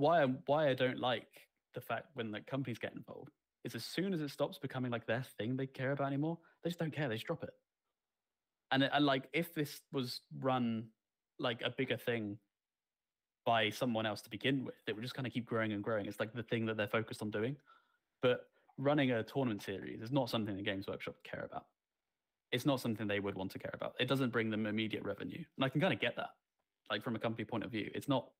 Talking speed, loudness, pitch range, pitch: 245 wpm, -38 LUFS, 110-140 Hz, 125 Hz